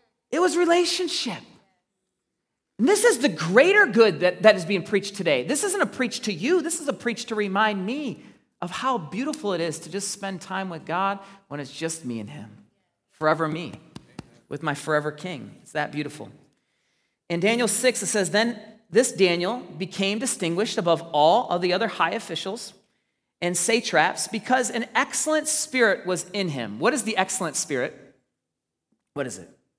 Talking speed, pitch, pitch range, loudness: 175 wpm, 200 Hz, 170-240 Hz, -23 LUFS